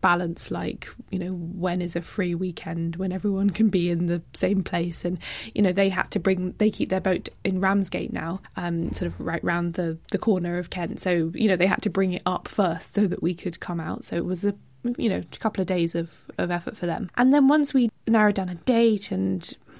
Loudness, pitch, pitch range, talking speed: -25 LUFS, 185 Hz, 175-205 Hz, 245 wpm